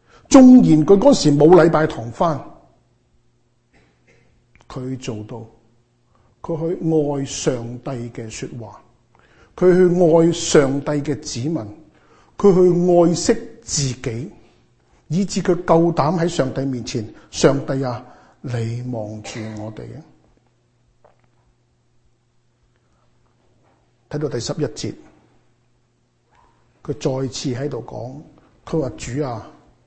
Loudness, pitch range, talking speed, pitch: -17 LUFS, 115-160 Hz, 140 characters per minute, 135 Hz